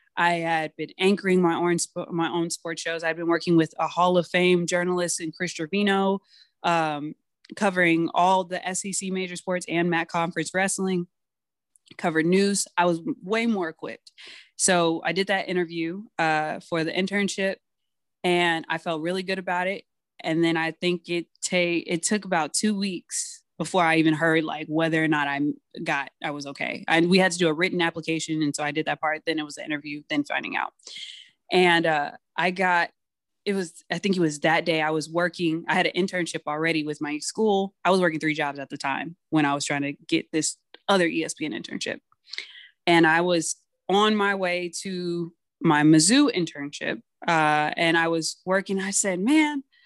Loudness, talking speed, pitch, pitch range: -24 LUFS, 195 wpm, 170 Hz, 160-185 Hz